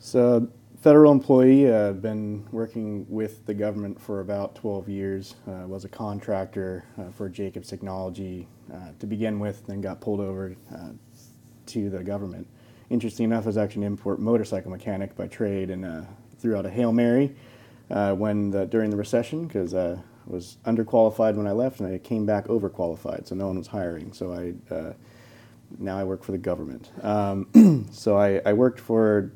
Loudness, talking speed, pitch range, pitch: -24 LUFS, 185 wpm, 95-115 Hz, 105 Hz